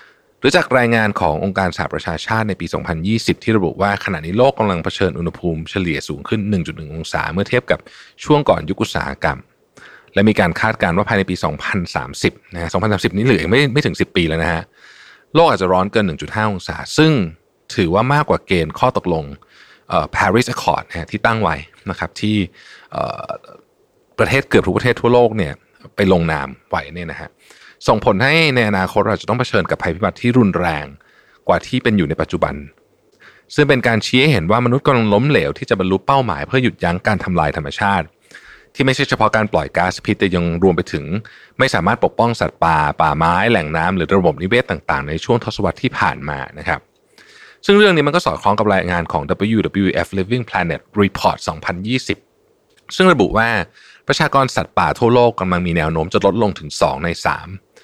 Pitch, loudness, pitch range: 100 Hz, -17 LUFS, 85-120 Hz